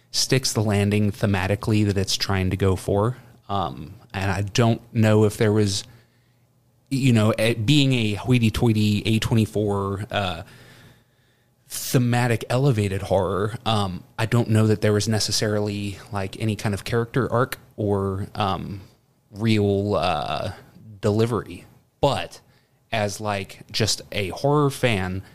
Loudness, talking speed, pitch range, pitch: -22 LUFS, 135 wpm, 100-120 Hz, 110 Hz